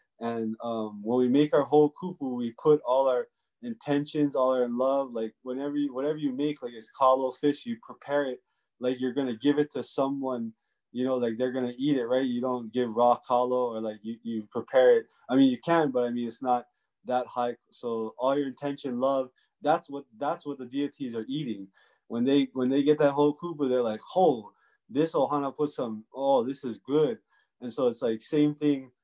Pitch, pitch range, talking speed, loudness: 130 Hz, 120-145 Hz, 215 wpm, -28 LUFS